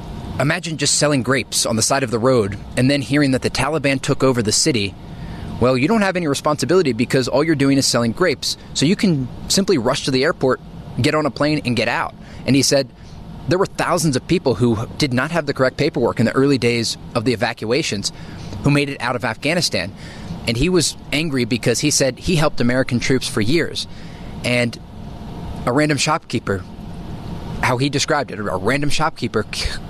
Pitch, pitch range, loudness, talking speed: 135 Hz, 120-150 Hz, -18 LUFS, 200 wpm